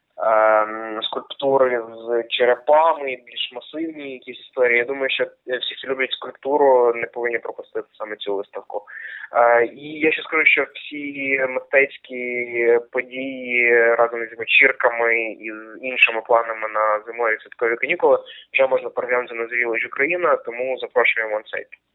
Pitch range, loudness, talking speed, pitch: 115-150 Hz, -19 LUFS, 135 wpm, 125 Hz